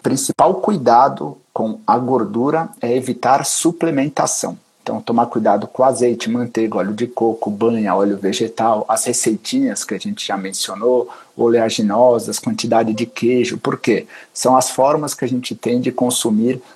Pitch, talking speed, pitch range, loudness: 120 Hz, 145 wpm, 115-130 Hz, -17 LUFS